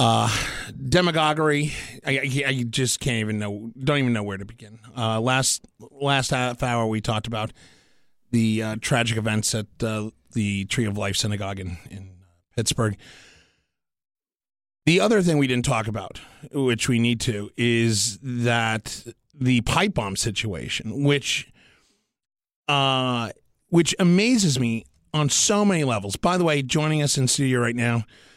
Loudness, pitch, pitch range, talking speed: -23 LUFS, 120 Hz, 110-140 Hz, 150 wpm